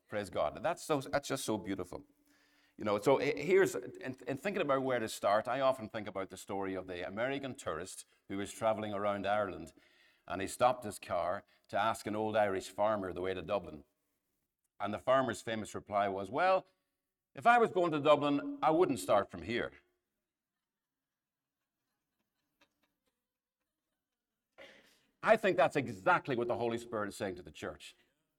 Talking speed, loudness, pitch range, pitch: 170 wpm, -34 LUFS, 95-135 Hz, 110 Hz